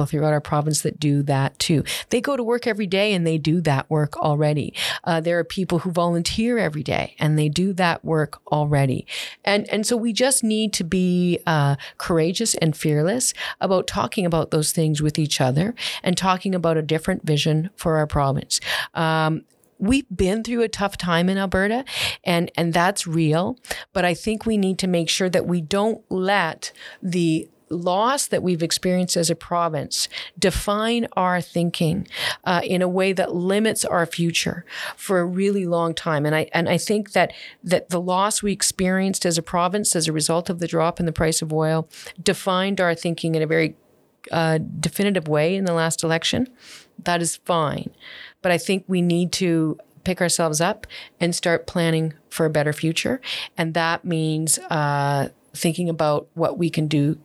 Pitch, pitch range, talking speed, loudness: 170 Hz, 160-190 Hz, 185 wpm, -21 LUFS